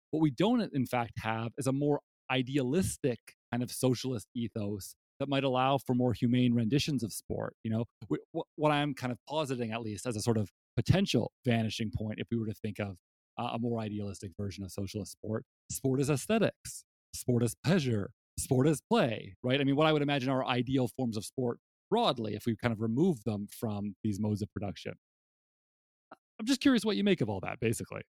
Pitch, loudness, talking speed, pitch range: 120 Hz, -32 LUFS, 205 wpm, 110-135 Hz